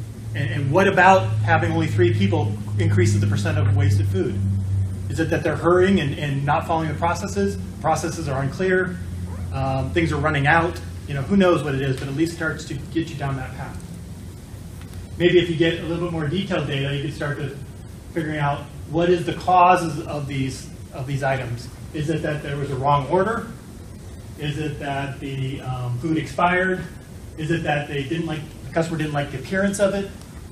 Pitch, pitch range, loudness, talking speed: 140 Hz, 110-165 Hz, -22 LUFS, 205 wpm